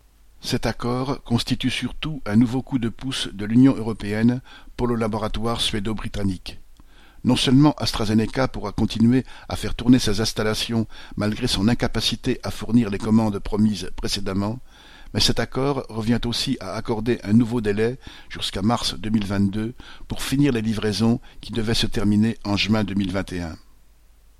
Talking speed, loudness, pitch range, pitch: 145 wpm, -22 LUFS, 105-120 Hz, 115 Hz